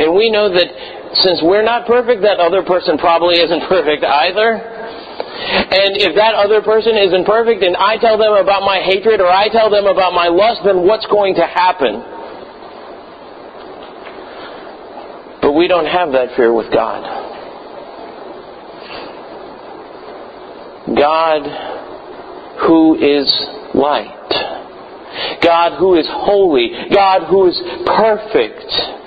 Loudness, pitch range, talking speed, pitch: -12 LUFS, 175-220 Hz, 125 wpm, 195 Hz